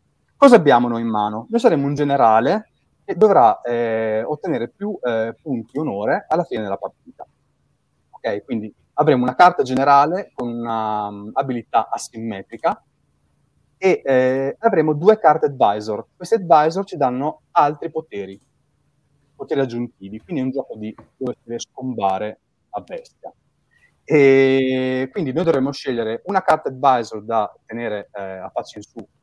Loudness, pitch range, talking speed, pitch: -19 LUFS, 110-150 Hz, 145 wpm, 130 Hz